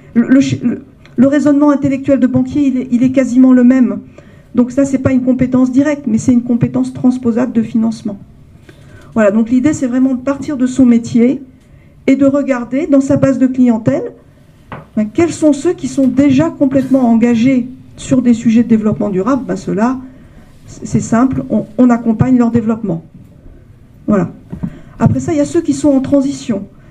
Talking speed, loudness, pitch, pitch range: 185 wpm, -12 LUFS, 255 Hz, 235-275 Hz